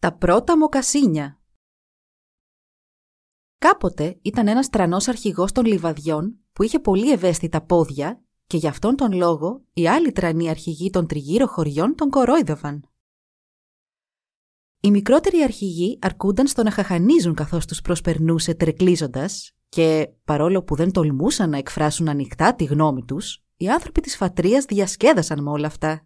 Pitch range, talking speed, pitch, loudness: 155-215 Hz, 135 wpm, 175 Hz, -20 LUFS